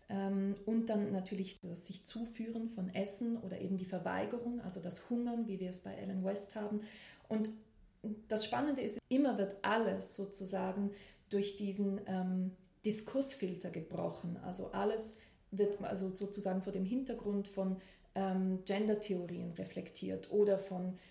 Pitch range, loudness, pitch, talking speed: 190-215 Hz, -38 LUFS, 200 Hz, 140 wpm